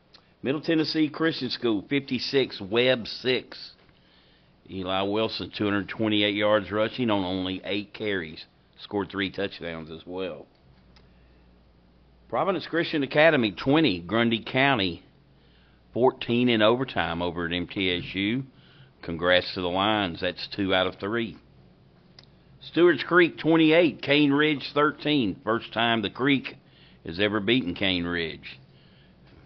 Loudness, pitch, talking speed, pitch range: -25 LUFS, 105 Hz, 115 wpm, 90-130 Hz